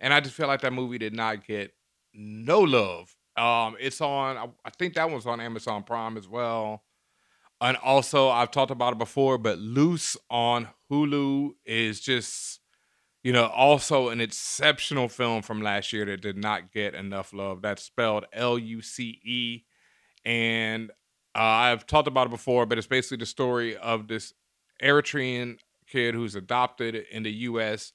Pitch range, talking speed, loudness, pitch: 110-130 Hz, 165 wpm, -26 LUFS, 120 Hz